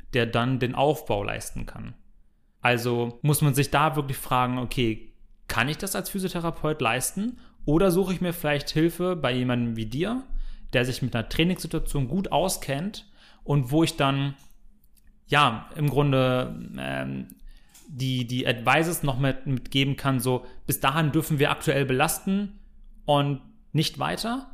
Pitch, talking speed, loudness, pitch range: 140 Hz, 150 wpm, -25 LUFS, 125-165 Hz